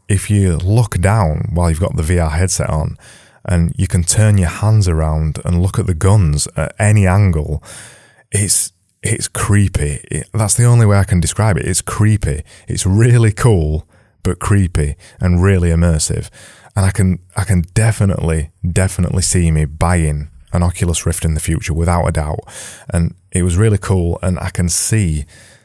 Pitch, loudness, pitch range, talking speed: 95 Hz, -15 LUFS, 85-105 Hz, 180 wpm